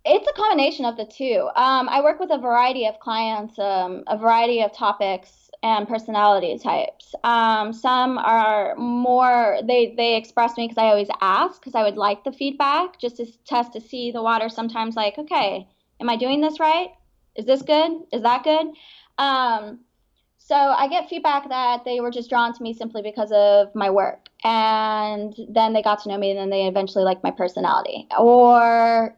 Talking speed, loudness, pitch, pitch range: 190 wpm, -20 LUFS, 235 Hz, 215-260 Hz